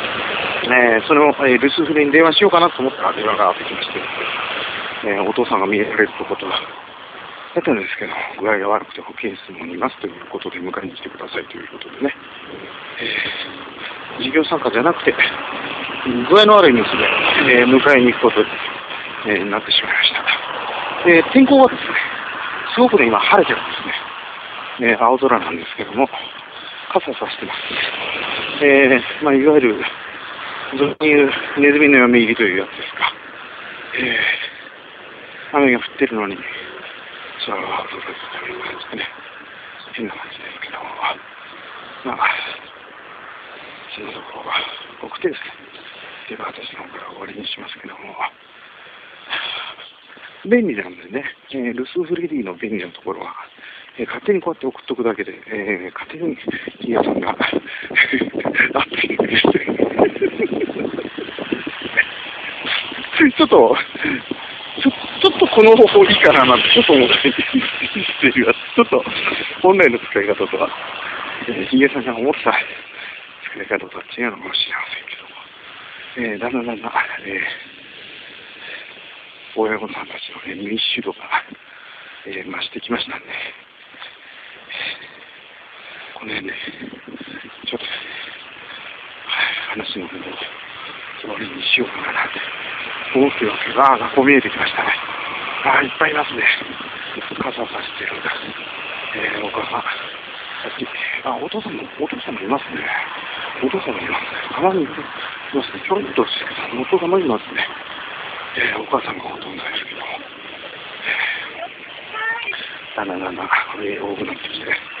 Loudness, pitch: -17 LUFS, 165 Hz